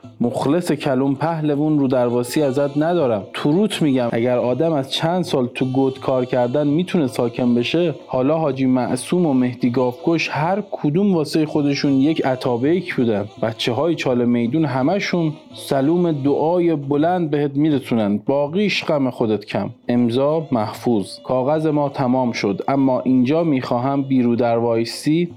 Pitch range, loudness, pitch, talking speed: 125-160 Hz, -19 LUFS, 135 Hz, 140 wpm